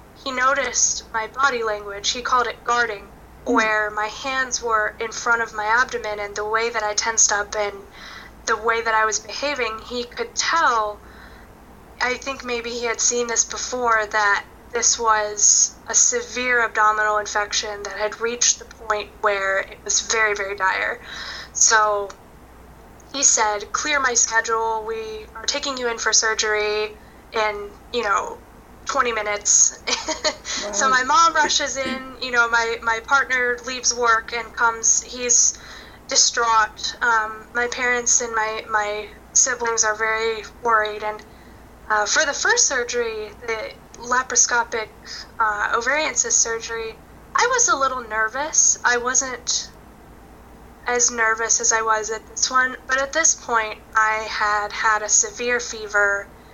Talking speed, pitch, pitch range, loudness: 150 wpm, 225 Hz, 215-250 Hz, -19 LUFS